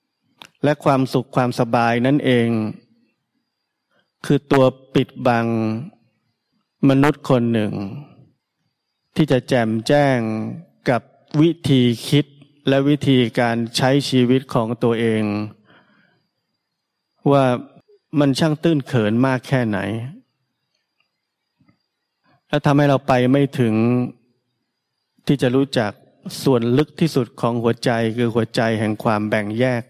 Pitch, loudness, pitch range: 130 Hz, -19 LUFS, 115-140 Hz